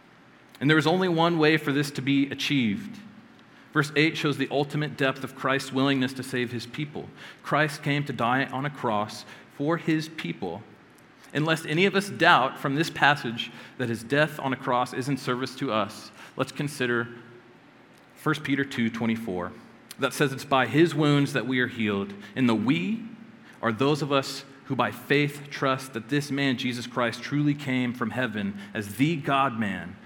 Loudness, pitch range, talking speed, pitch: -26 LUFS, 125-150 Hz, 190 wpm, 135 Hz